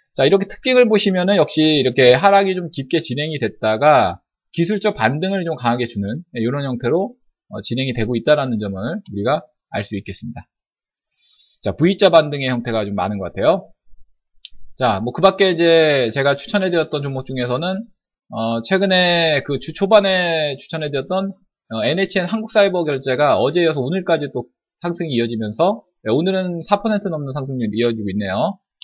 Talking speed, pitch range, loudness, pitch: 340 characters per minute, 120-190 Hz, -18 LUFS, 150 Hz